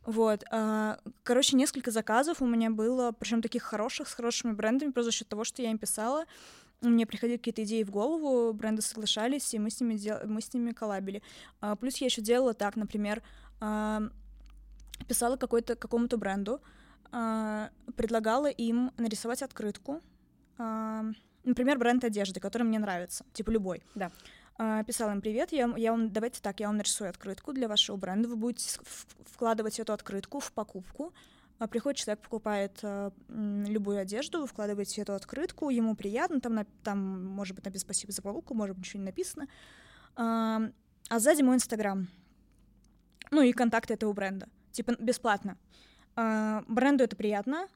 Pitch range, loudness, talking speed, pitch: 210-245 Hz, -32 LUFS, 155 wpm, 225 Hz